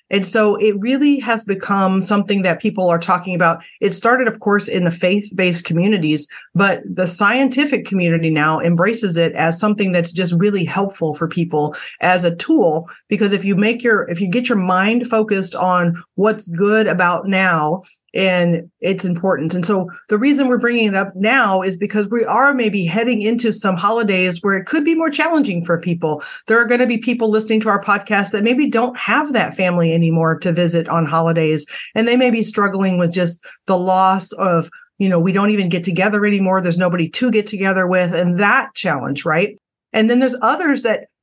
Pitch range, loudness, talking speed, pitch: 175-220 Hz, -16 LUFS, 200 wpm, 195 Hz